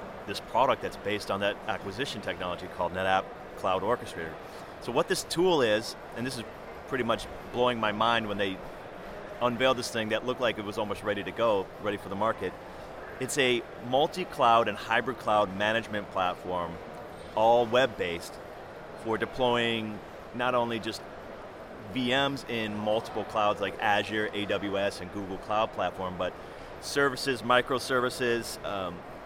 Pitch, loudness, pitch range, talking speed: 110 Hz, -29 LUFS, 100-125 Hz, 155 wpm